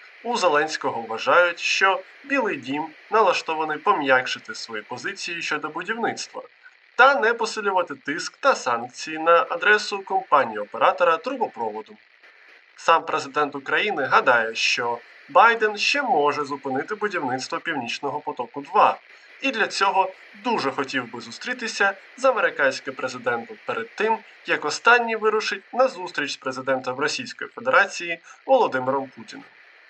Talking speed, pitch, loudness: 115 wpm, 195 Hz, -22 LUFS